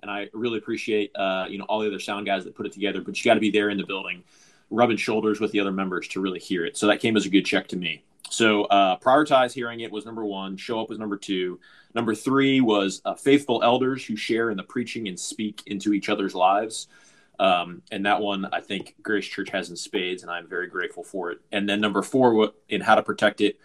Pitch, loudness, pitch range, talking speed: 105 Hz, -24 LUFS, 100-110 Hz, 255 wpm